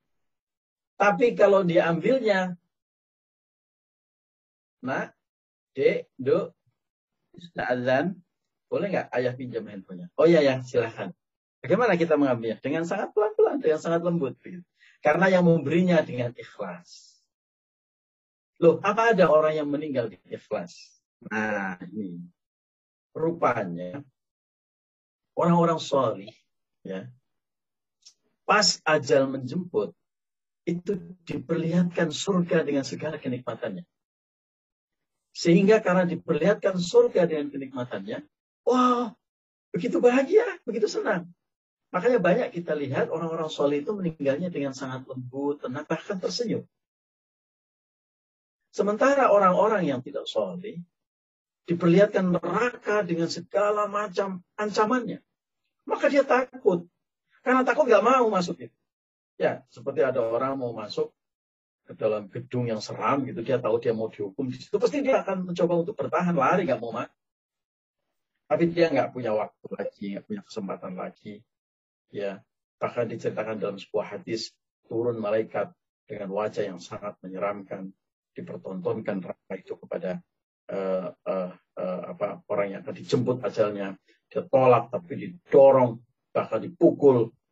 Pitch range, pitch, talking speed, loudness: 120-200 Hz, 165 Hz, 115 wpm, -25 LUFS